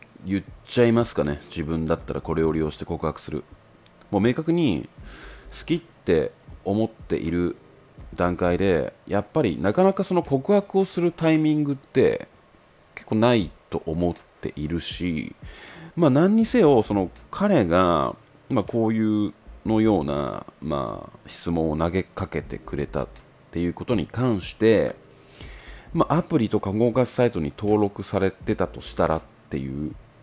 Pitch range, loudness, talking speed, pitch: 80-120 Hz, -24 LUFS, 290 characters per minute, 100 Hz